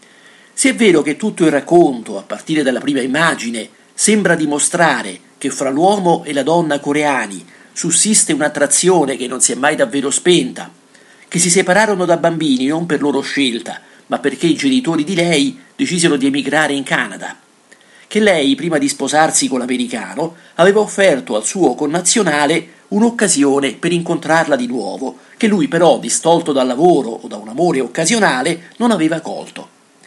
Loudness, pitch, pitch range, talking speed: -14 LUFS, 165 Hz, 145-200 Hz, 160 wpm